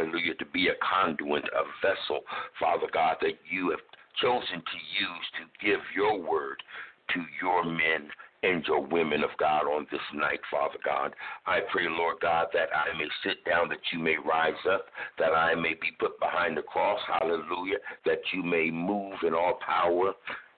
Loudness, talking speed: -29 LUFS, 180 wpm